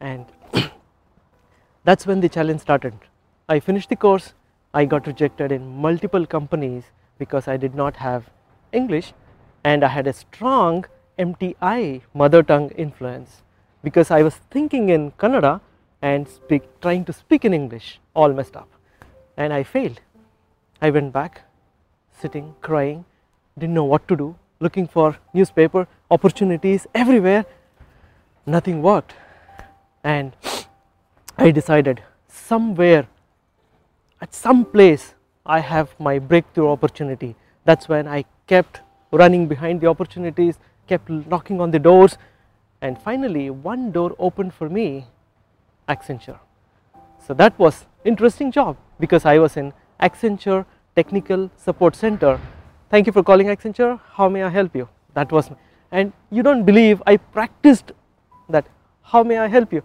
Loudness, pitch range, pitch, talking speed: -18 LUFS, 130-190 Hz, 155 Hz, 140 wpm